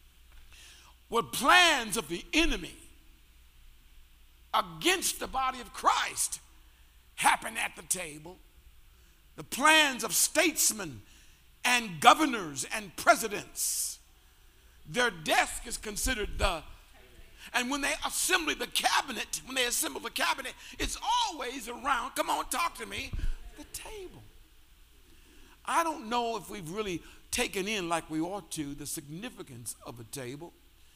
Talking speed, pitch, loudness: 125 wpm, 190 Hz, -29 LUFS